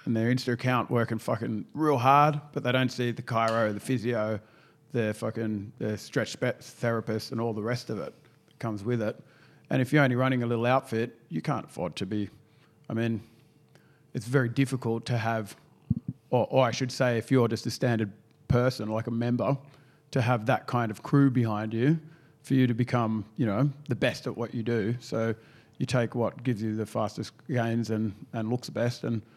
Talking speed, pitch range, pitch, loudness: 200 wpm, 115-135 Hz, 120 Hz, -29 LUFS